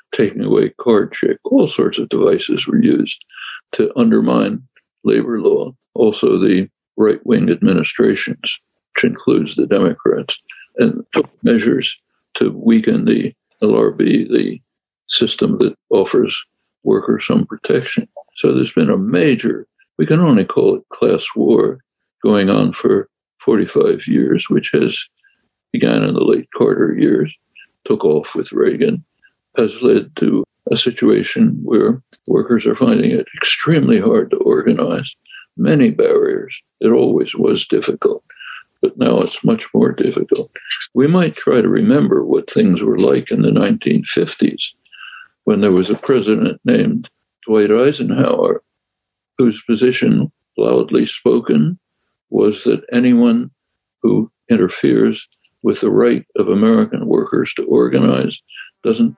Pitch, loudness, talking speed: 390 Hz, -15 LUFS, 130 wpm